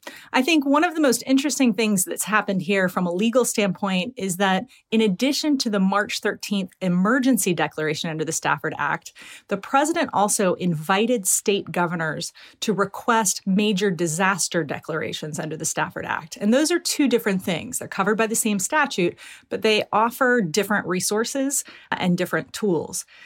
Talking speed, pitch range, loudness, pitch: 165 wpm, 185-240 Hz, -22 LUFS, 205 Hz